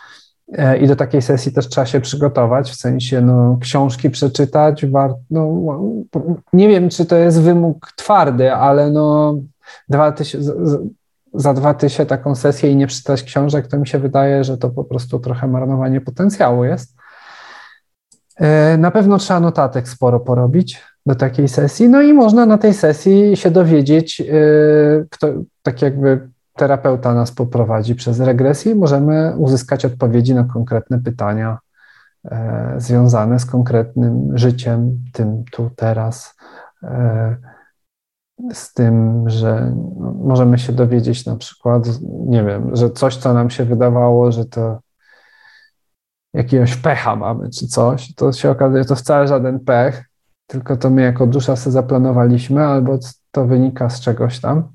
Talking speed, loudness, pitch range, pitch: 145 wpm, -14 LUFS, 125-150 Hz, 135 Hz